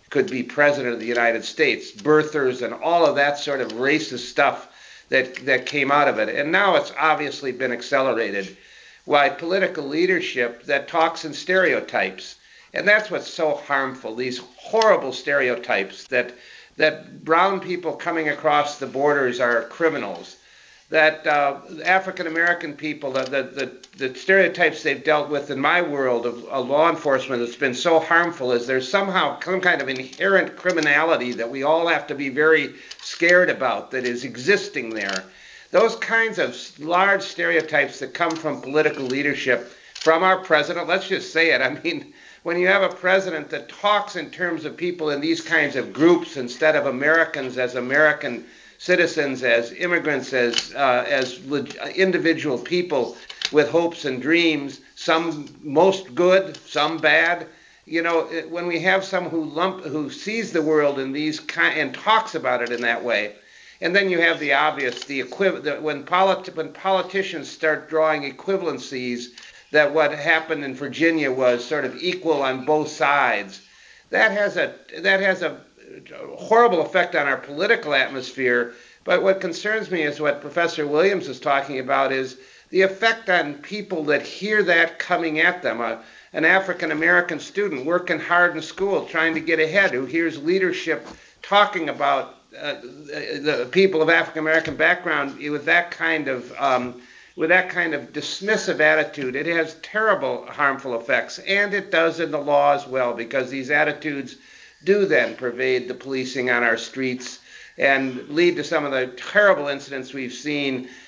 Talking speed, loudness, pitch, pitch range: 165 wpm, -21 LUFS, 155 Hz, 140-180 Hz